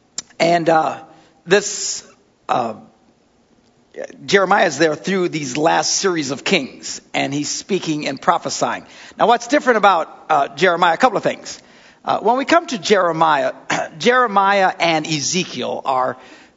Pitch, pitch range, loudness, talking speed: 185 Hz, 160-215 Hz, -17 LUFS, 140 wpm